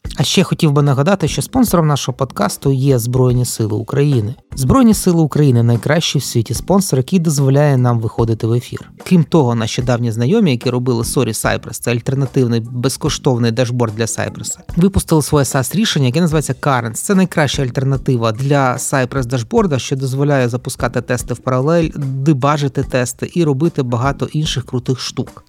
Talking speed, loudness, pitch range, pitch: 160 wpm, -15 LUFS, 125-150 Hz, 135 Hz